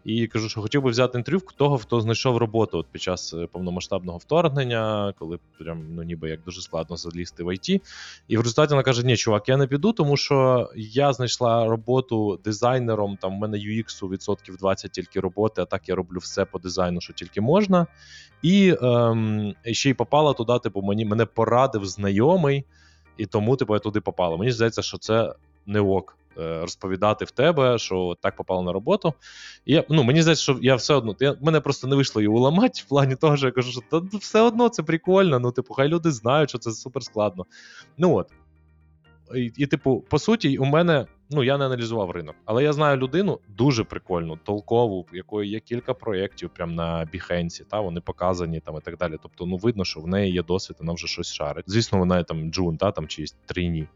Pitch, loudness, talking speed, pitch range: 110 Hz, -23 LUFS, 205 wpm, 90-135 Hz